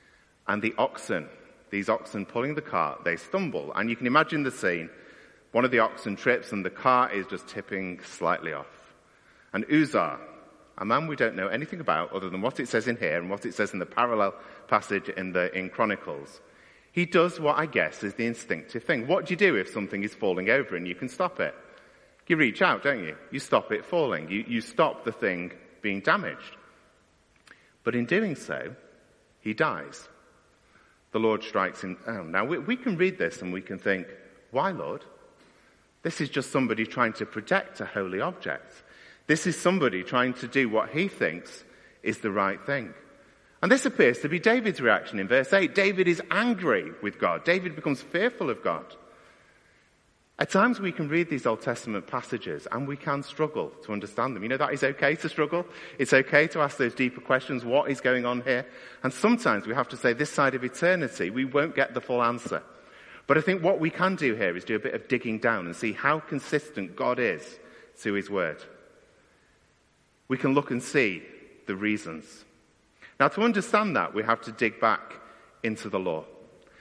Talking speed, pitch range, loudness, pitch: 200 wpm, 110-155 Hz, -27 LUFS, 130 Hz